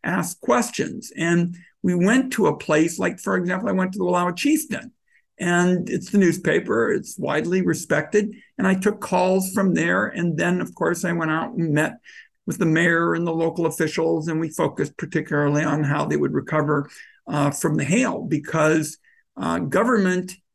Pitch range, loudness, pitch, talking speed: 160-190 Hz, -22 LUFS, 175 Hz, 180 wpm